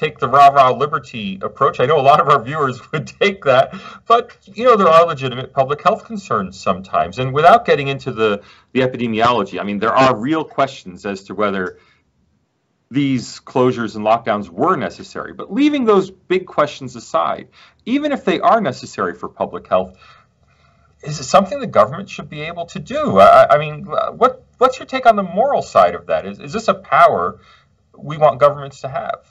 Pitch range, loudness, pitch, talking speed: 130-195 Hz, -16 LUFS, 150 Hz, 190 wpm